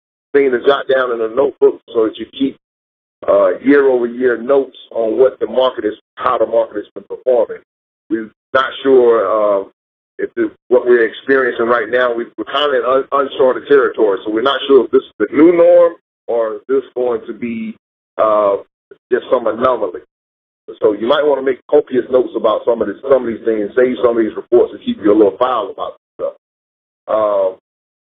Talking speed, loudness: 200 wpm, -14 LUFS